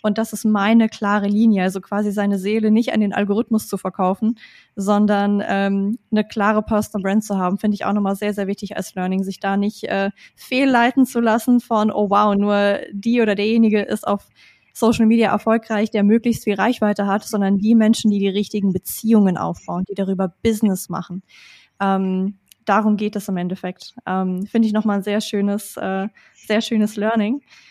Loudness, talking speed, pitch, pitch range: -19 LUFS, 190 wpm, 210 Hz, 195-220 Hz